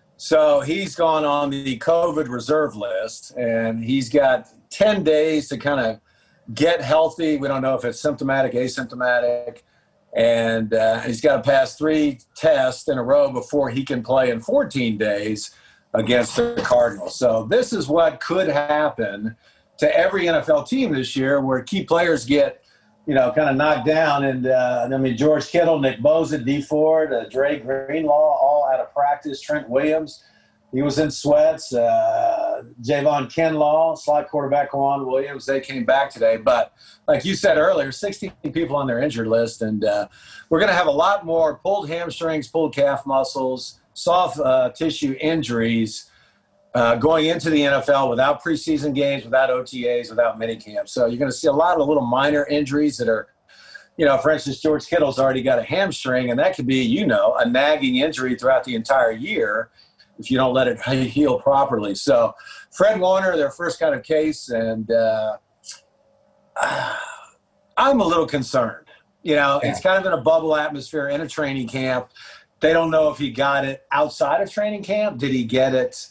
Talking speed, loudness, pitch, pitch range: 180 wpm, -20 LUFS, 145 Hz, 130-160 Hz